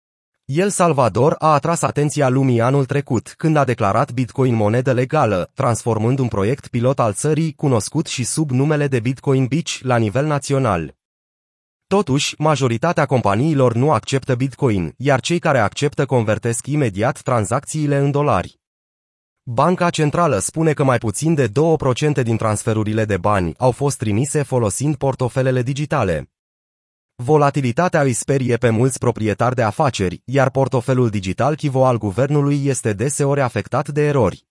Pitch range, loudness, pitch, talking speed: 115-145 Hz, -18 LUFS, 130 Hz, 145 wpm